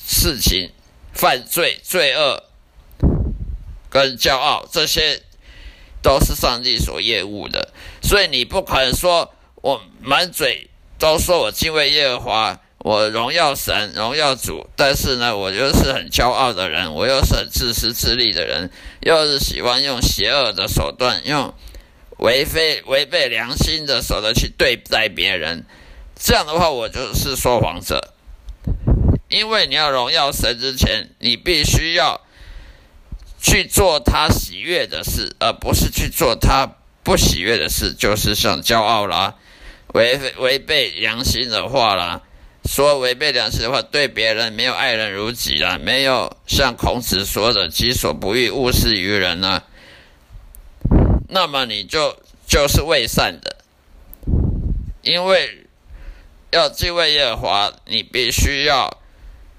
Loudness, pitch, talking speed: -17 LUFS, 105 Hz, 200 characters per minute